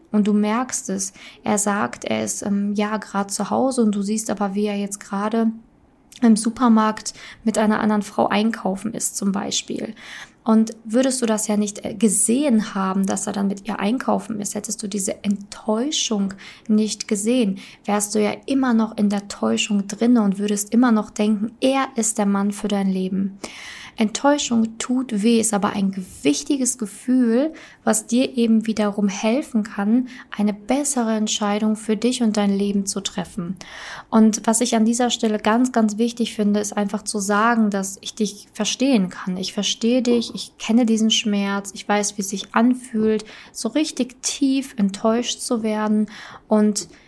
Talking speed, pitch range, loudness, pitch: 175 wpm, 205-235 Hz, -21 LUFS, 215 Hz